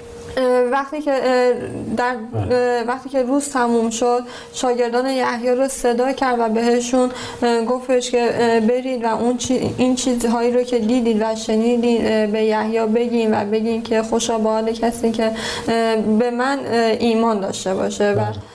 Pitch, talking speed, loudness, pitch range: 240 Hz, 140 wpm, -18 LUFS, 225-250 Hz